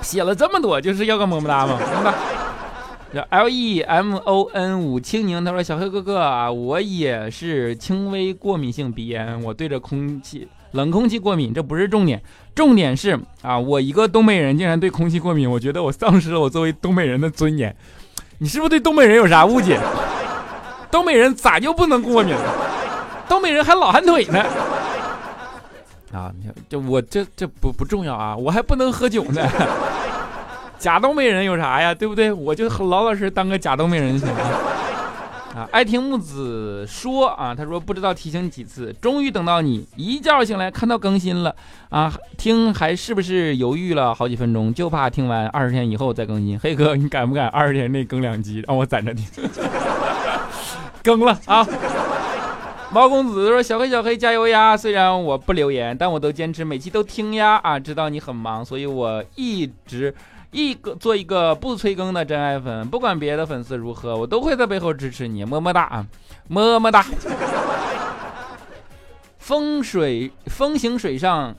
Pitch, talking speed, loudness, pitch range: 170 Hz, 265 characters per minute, -19 LUFS, 130-215 Hz